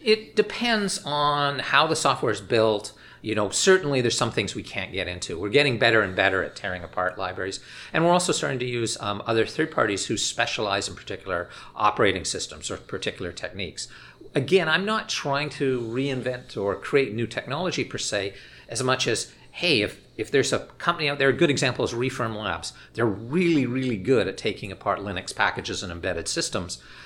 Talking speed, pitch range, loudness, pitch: 195 wpm, 110-145 Hz, -25 LUFS, 125 Hz